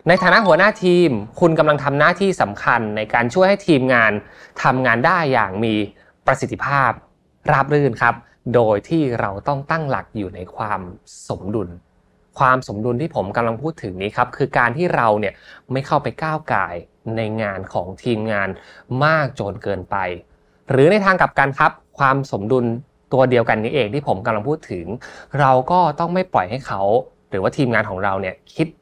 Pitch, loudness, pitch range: 125 Hz, -18 LUFS, 105-150 Hz